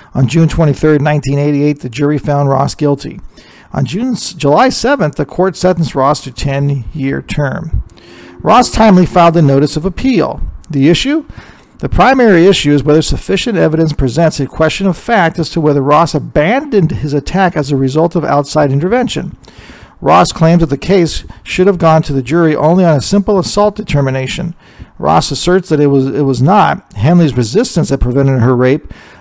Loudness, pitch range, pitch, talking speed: -11 LUFS, 140-180 Hz, 155 Hz, 175 wpm